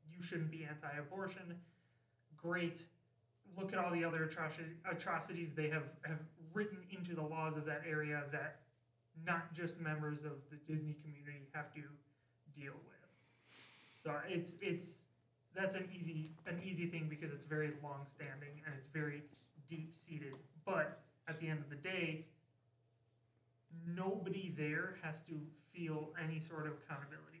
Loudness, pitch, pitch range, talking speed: -45 LUFS, 155 Hz, 145-170 Hz, 150 wpm